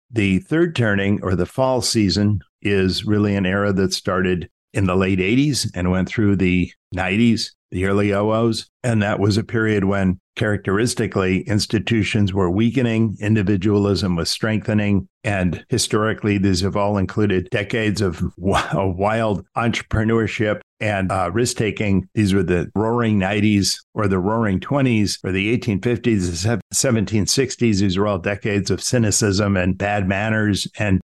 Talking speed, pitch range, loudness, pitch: 150 wpm, 95-110 Hz, -19 LUFS, 105 Hz